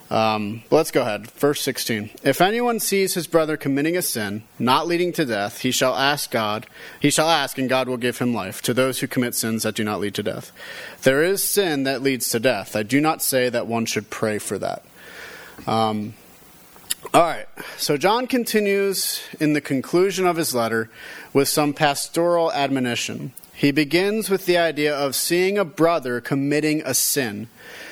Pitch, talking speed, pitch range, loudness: 140 Hz, 185 wpm, 120-170 Hz, -21 LUFS